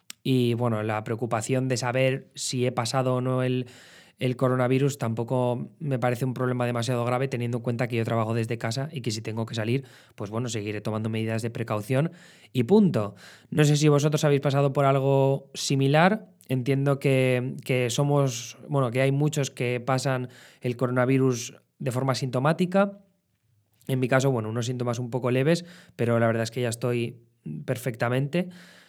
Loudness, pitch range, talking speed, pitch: -26 LUFS, 120-135 Hz, 175 wpm, 130 Hz